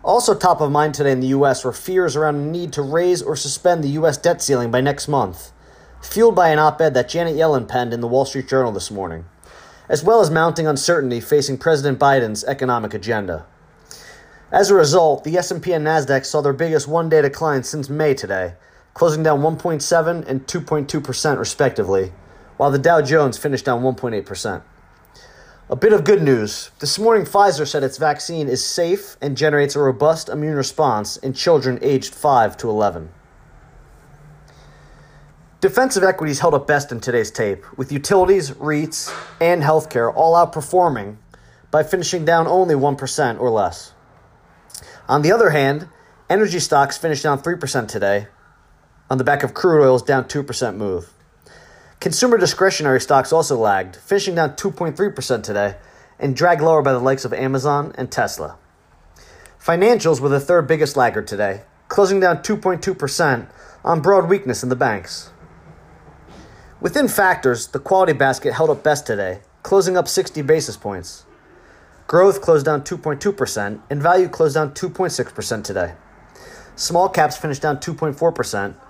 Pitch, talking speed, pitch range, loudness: 150 Hz, 155 wpm, 130-170 Hz, -18 LUFS